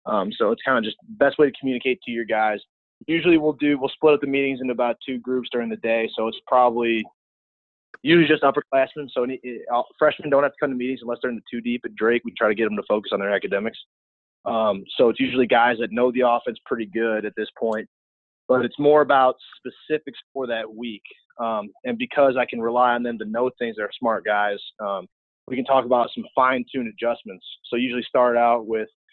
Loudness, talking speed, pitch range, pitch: -22 LUFS, 230 wpm, 115-140 Hz, 125 Hz